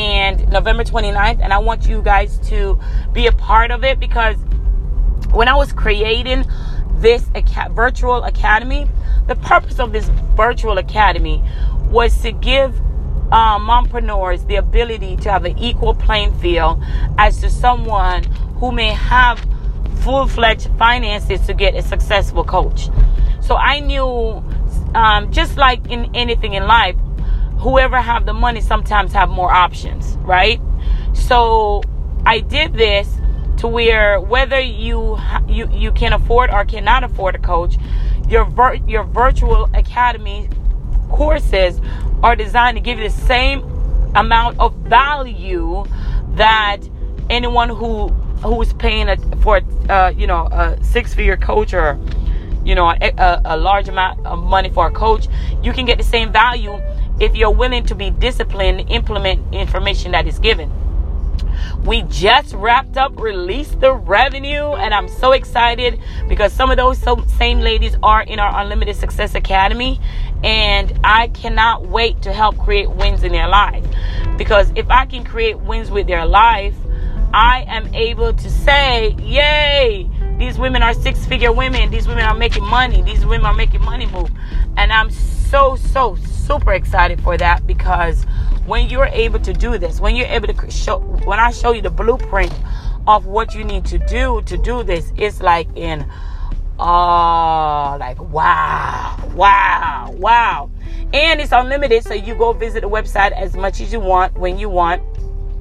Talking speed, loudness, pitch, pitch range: 155 wpm, -15 LUFS, 230 Hz, 180-270 Hz